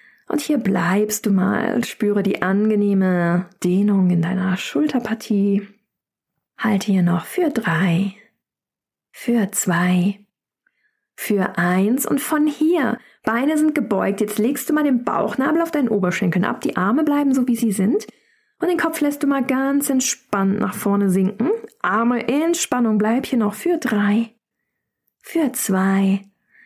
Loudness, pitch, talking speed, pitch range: -19 LUFS, 220 Hz, 145 wpm, 195-280 Hz